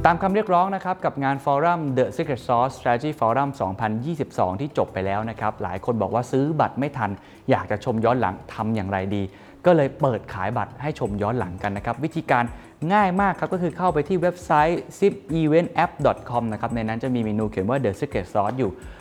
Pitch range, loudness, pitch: 110-160 Hz, -23 LUFS, 130 Hz